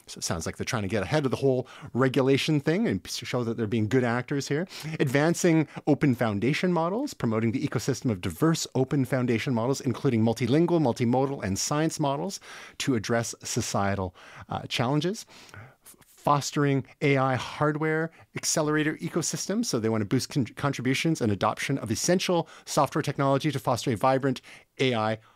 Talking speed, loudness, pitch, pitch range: 160 wpm, -27 LUFS, 135 Hz, 120-155 Hz